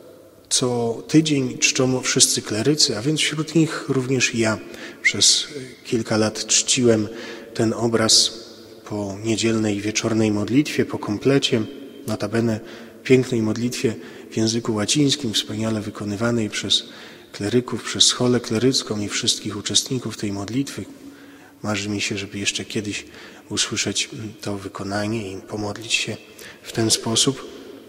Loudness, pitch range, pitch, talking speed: -20 LUFS, 105-130 Hz, 115 Hz, 125 wpm